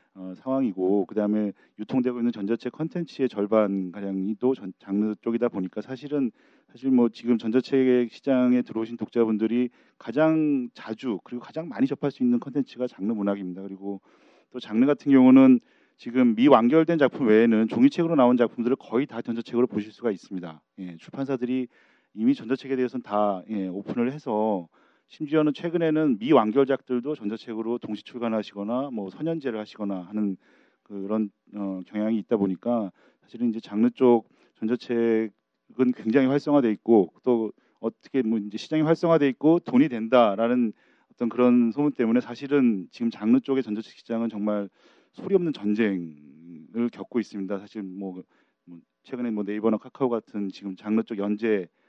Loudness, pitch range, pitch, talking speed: -25 LUFS, 105-130 Hz, 115 Hz, 360 characters per minute